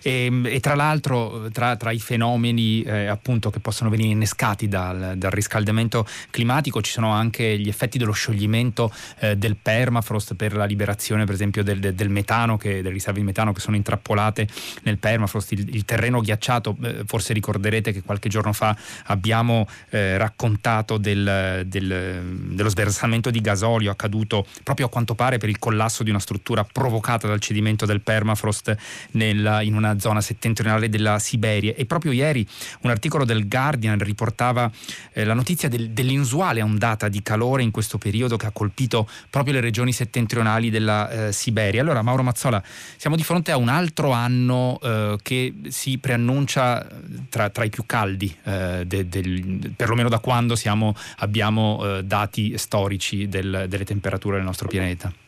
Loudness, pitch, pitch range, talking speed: -22 LUFS, 110 Hz, 105-120 Hz, 165 wpm